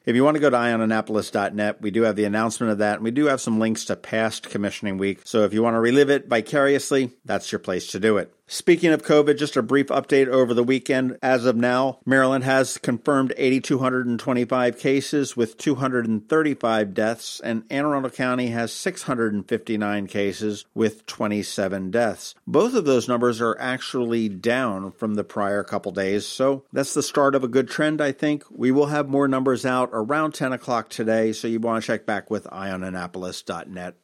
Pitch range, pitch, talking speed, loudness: 110-135 Hz, 120 Hz, 190 wpm, -22 LUFS